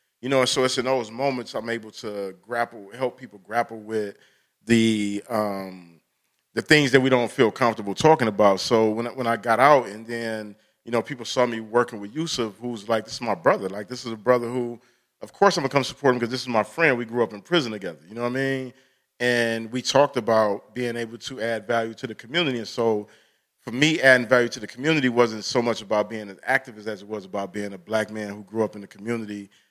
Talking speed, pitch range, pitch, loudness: 245 wpm, 110-130 Hz, 115 Hz, -23 LUFS